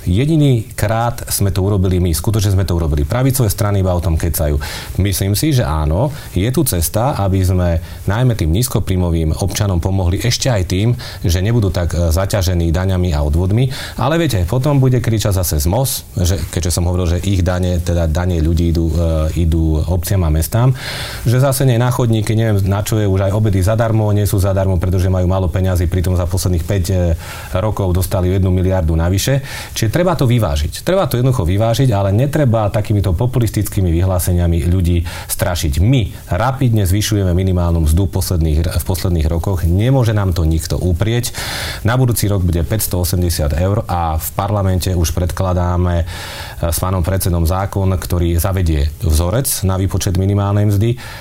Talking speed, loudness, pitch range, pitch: 165 wpm, -16 LUFS, 90-110 Hz, 95 Hz